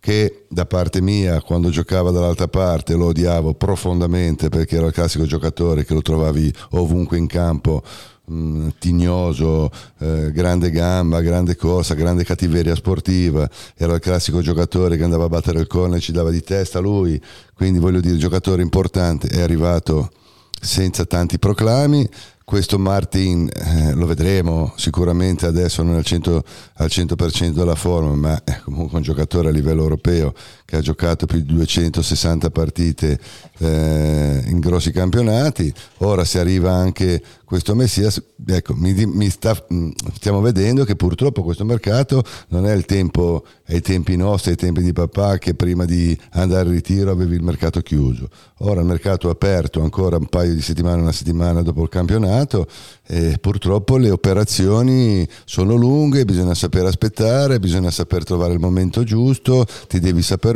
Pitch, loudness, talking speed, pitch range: 90 Hz, -18 LUFS, 160 wpm, 85-95 Hz